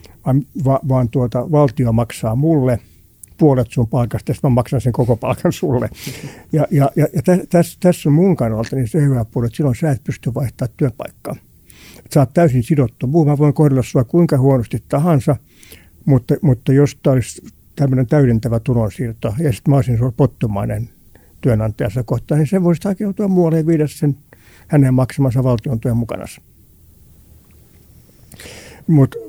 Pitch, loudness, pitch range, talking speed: 130 Hz, -16 LUFS, 115-150 Hz, 160 wpm